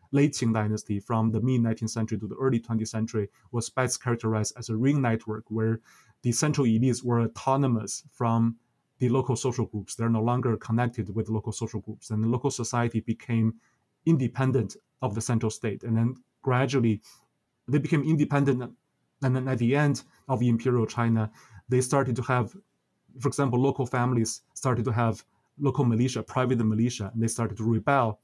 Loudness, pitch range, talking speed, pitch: -27 LUFS, 110-130 Hz, 175 wpm, 120 Hz